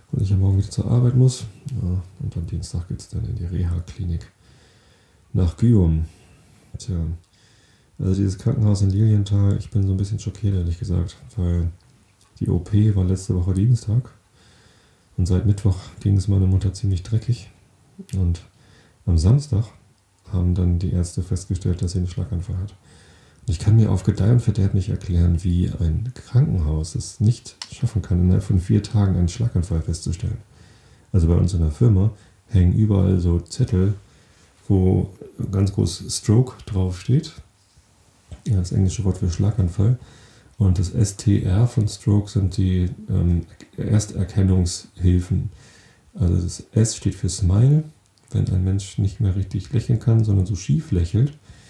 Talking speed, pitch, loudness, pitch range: 155 wpm, 100 Hz, -21 LUFS, 90-110 Hz